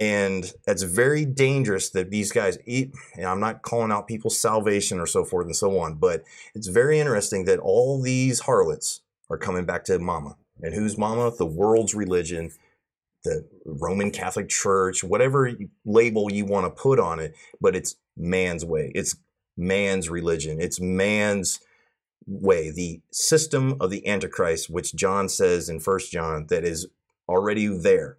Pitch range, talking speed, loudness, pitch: 90-130 Hz, 165 wpm, -24 LUFS, 105 Hz